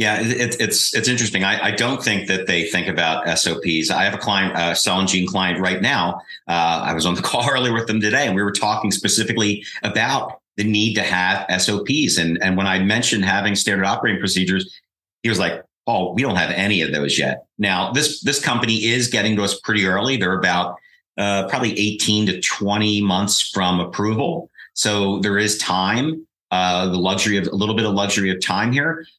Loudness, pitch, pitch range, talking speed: -18 LUFS, 100 Hz, 95-110 Hz, 205 wpm